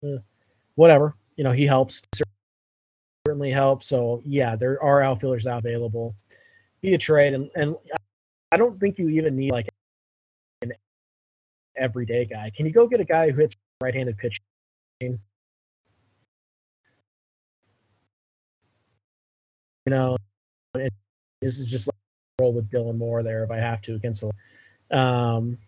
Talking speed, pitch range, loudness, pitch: 135 wpm, 105-135 Hz, -23 LUFS, 120 Hz